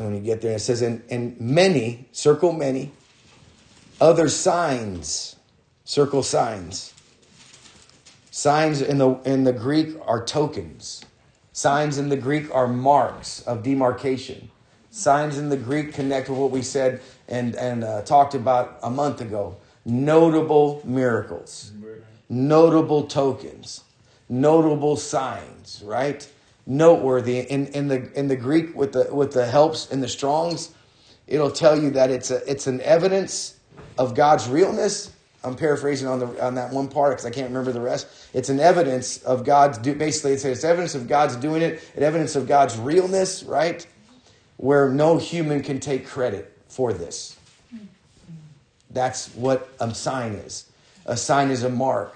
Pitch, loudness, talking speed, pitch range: 135 Hz, -21 LUFS, 155 wpm, 125-150 Hz